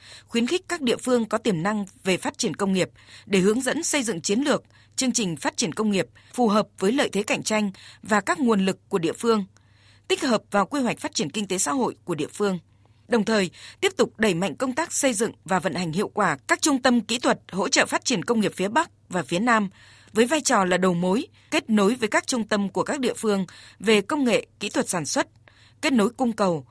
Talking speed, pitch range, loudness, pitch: 250 wpm, 190-255 Hz, -24 LUFS, 220 Hz